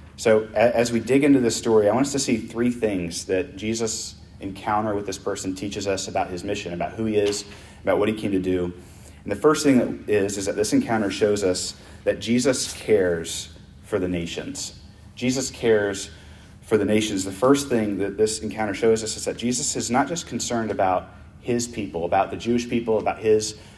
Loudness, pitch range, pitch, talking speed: -23 LUFS, 95-115 Hz, 105 Hz, 205 wpm